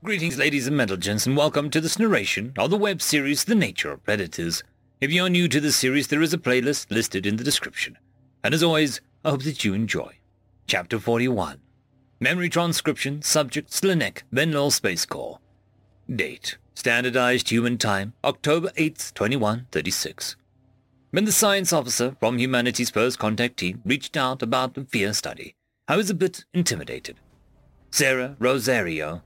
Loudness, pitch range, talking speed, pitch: -23 LUFS, 115-155 Hz, 165 wpm, 130 Hz